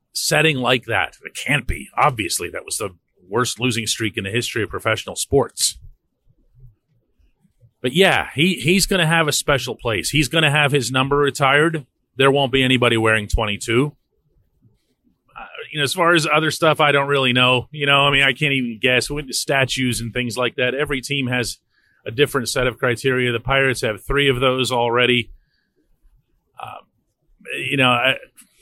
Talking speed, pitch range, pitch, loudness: 185 wpm, 120-145 Hz, 130 Hz, -18 LUFS